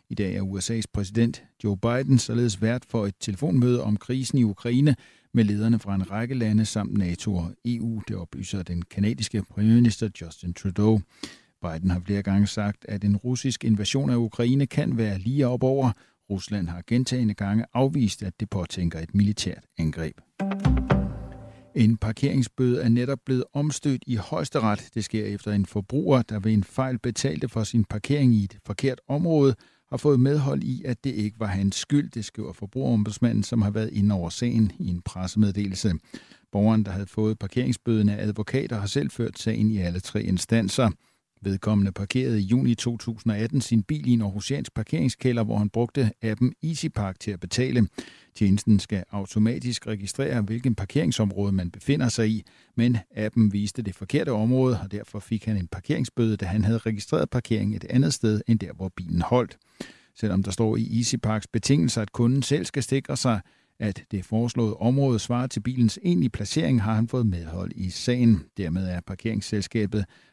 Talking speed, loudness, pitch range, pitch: 175 wpm, -25 LUFS, 100-125 Hz, 110 Hz